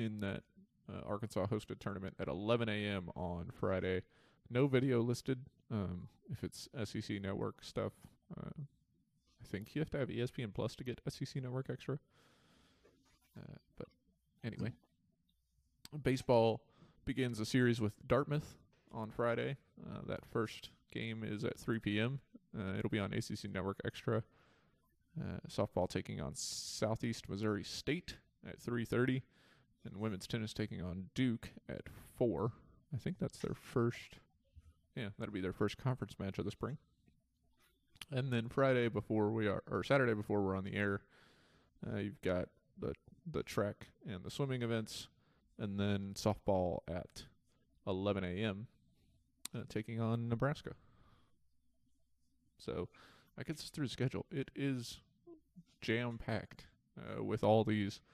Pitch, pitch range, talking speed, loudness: 110 Hz, 100-130 Hz, 145 wpm, -40 LUFS